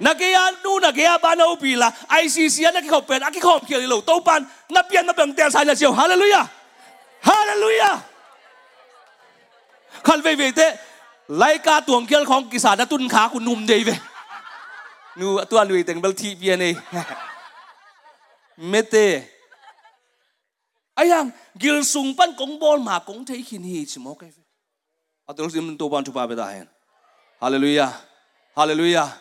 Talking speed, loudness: 70 wpm, -18 LUFS